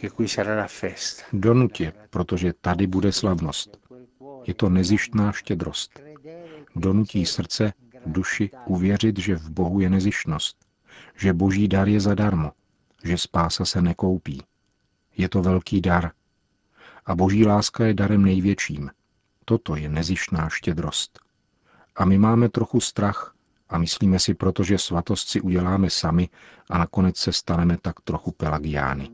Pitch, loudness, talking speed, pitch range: 95 Hz, -23 LUFS, 125 wpm, 90-105 Hz